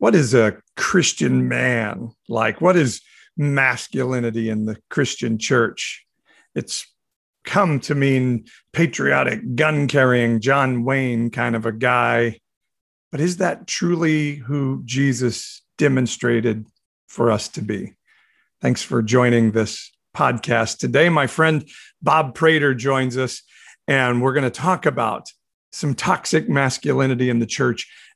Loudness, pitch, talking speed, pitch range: -19 LUFS, 130 Hz, 130 wpm, 115-145 Hz